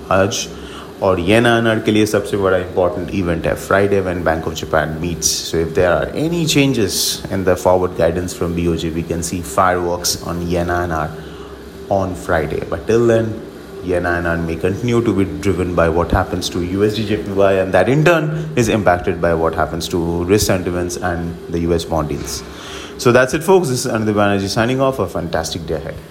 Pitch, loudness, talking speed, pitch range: 90 Hz, -17 LUFS, 185 wpm, 85-105 Hz